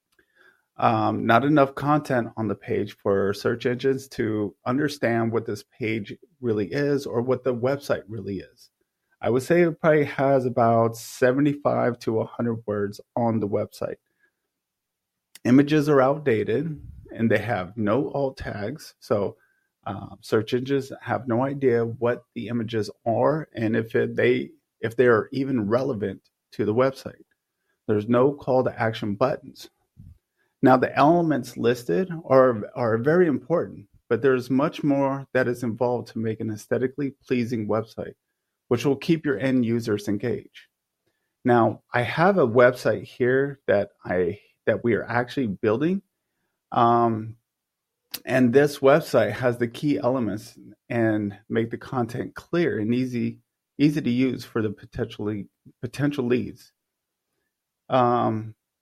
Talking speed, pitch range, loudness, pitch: 145 wpm, 115-135 Hz, -24 LUFS, 125 Hz